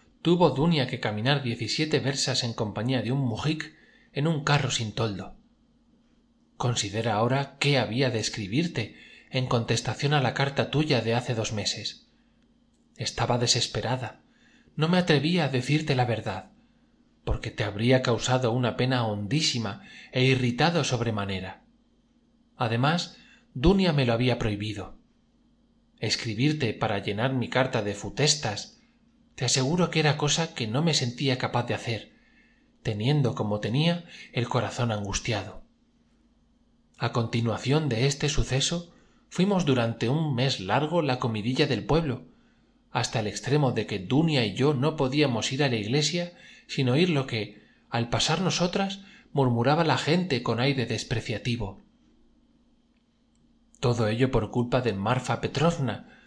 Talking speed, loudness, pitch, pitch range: 140 wpm, -26 LUFS, 130 Hz, 115-155 Hz